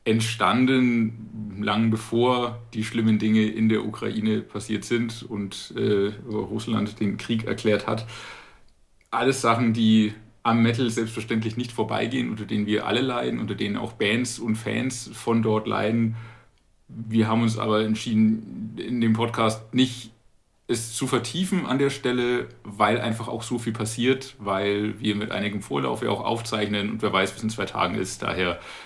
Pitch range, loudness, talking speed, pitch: 110-120 Hz, -25 LUFS, 160 wpm, 110 Hz